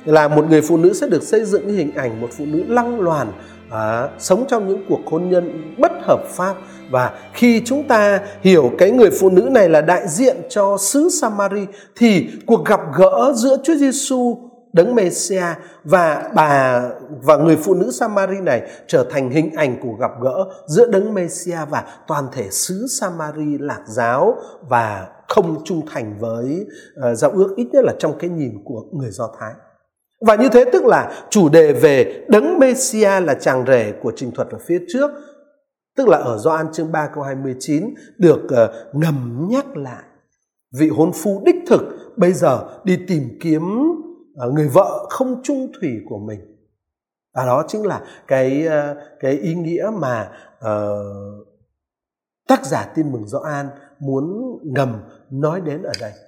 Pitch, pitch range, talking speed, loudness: 175 Hz, 145-235 Hz, 175 wpm, -17 LUFS